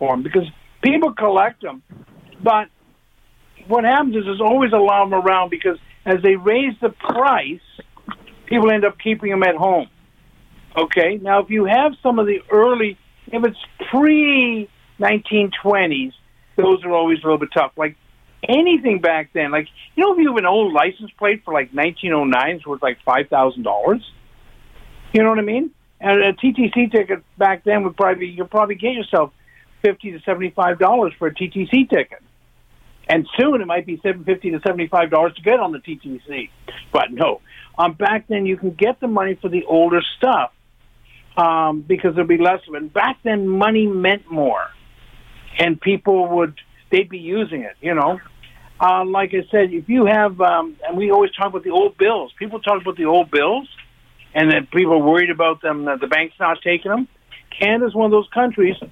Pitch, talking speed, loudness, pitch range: 190 Hz, 190 wpm, -17 LUFS, 165-215 Hz